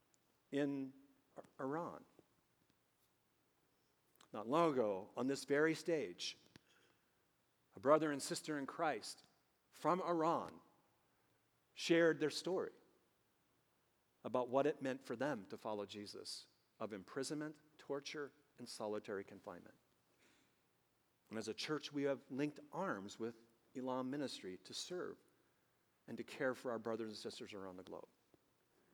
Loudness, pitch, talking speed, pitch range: -42 LUFS, 135 Hz, 120 wpm, 115-150 Hz